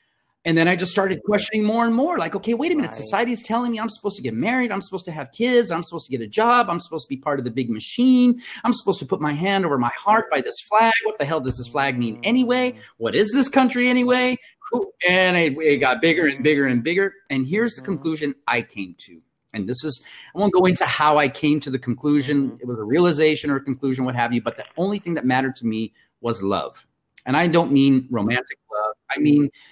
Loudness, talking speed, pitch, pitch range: -20 LUFS, 250 wpm, 165 Hz, 135-220 Hz